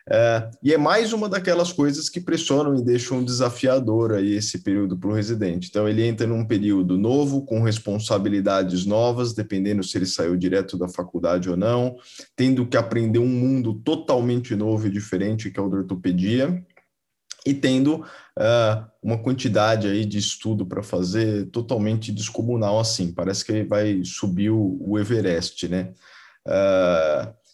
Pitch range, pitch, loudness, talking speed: 100-130 Hz, 110 Hz, -22 LUFS, 160 wpm